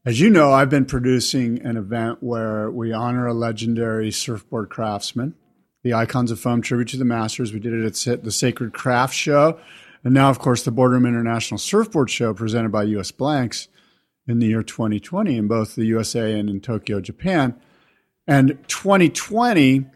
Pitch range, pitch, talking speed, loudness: 115-135 Hz, 120 Hz, 175 wpm, -20 LUFS